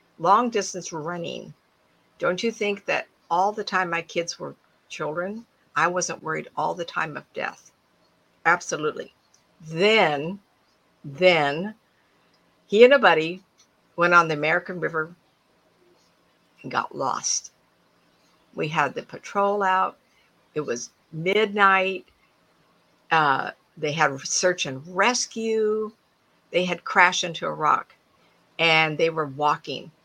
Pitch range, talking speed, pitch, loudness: 160-200 Hz, 120 wpm, 175 Hz, -23 LUFS